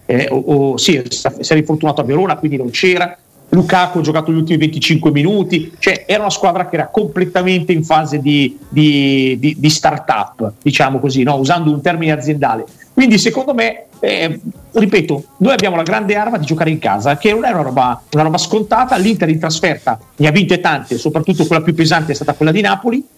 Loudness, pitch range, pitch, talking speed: -13 LUFS, 145-190 Hz, 160 Hz, 200 wpm